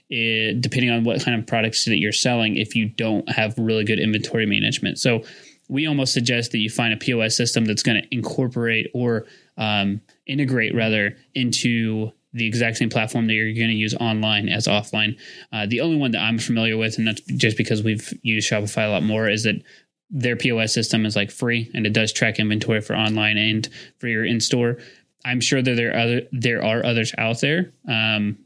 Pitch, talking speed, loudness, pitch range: 115 Hz, 210 wpm, -21 LUFS, 110-120 Hz